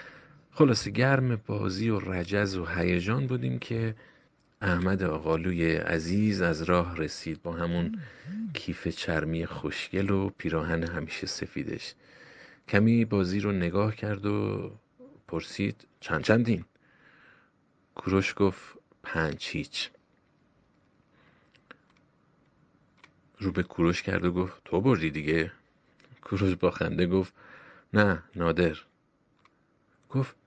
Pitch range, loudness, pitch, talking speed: 85-110 Hz, -29 LUFS, 95 Hz, 100 wpm